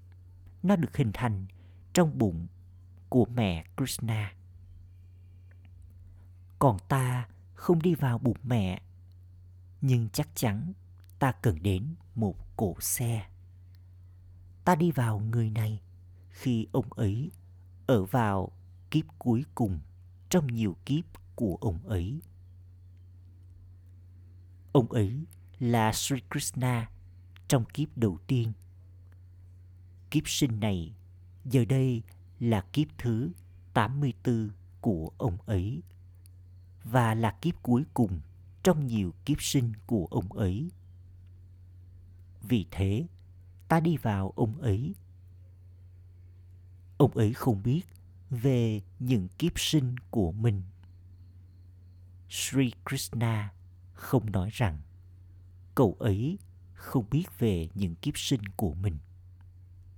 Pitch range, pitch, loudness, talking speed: 90-120 Hz, 95 Hz, -30 LUFS, 110 wpm